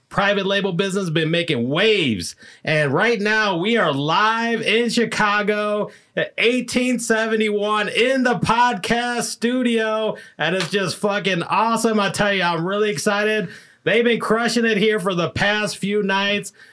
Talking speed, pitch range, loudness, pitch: 145 wpm, 195-225 Hz, -19 LUFS, 210 Hz